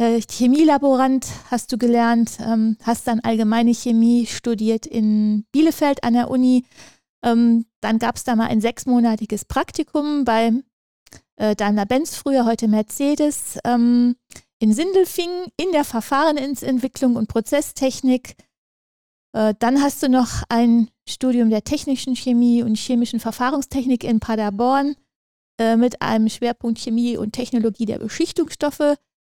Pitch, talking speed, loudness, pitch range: 240 Hz, 115 wpm, -19 LUFS, 225-270 Hz